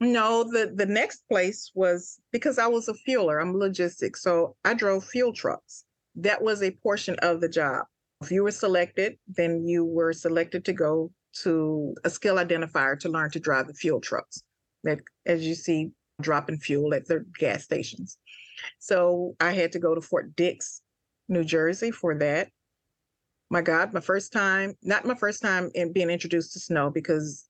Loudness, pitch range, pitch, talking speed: -26 LUFS, 165-200 Hz, 175 Hz, 180 wpm